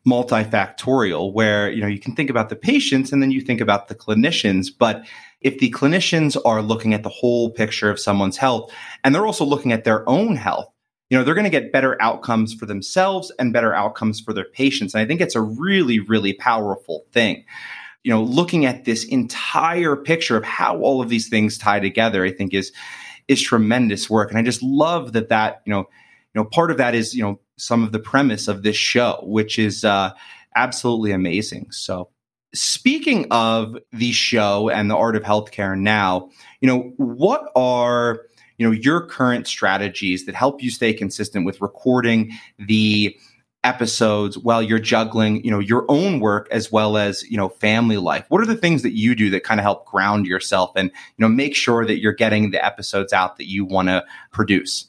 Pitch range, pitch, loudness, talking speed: 105-125 Hz, 115 Hz, -19 LUFS, 200 wpm